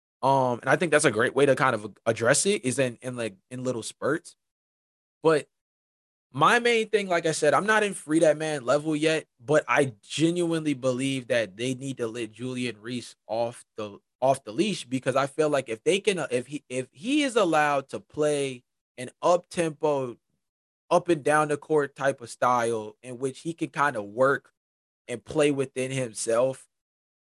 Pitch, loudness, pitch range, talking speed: 135 Hz, -26 LUFS, 125-155 Hz, 195 wpm